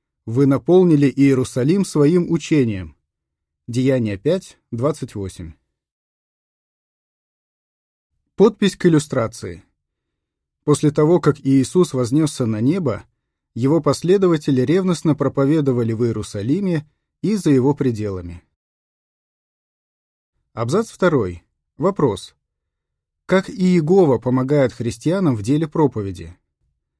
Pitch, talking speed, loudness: 135 Hz, 85 wpm, -18 LUFS